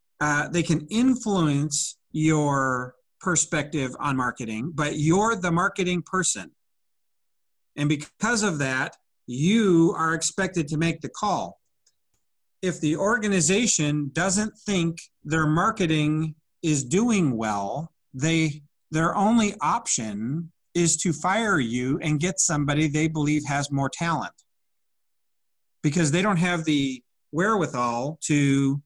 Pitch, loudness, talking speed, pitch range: 160 Hz, -24 LUFS, 120 wpm, 145-180 Hz